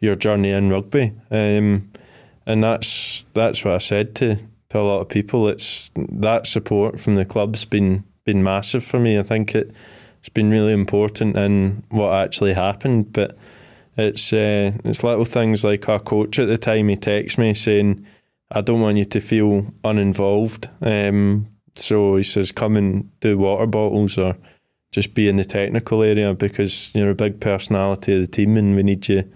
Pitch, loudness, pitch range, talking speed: 105 Hz, -19 LUFS, 100-110 Hz, 185 wpm